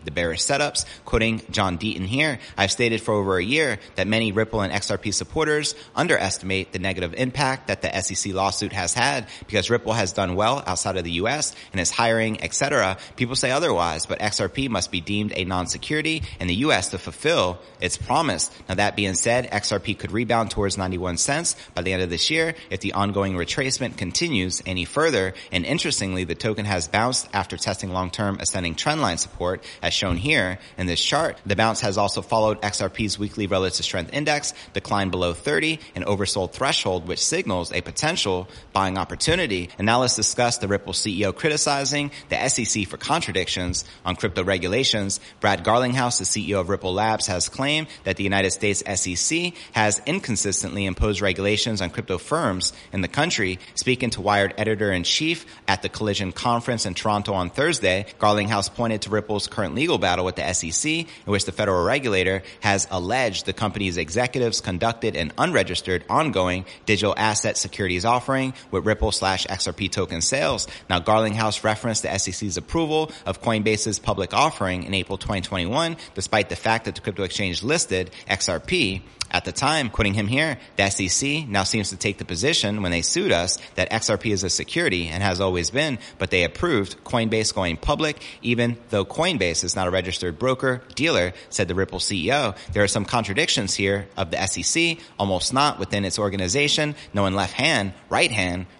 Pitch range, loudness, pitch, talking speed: 95-115 Hz, -23 LUFS, 100 Hz, 180 wpm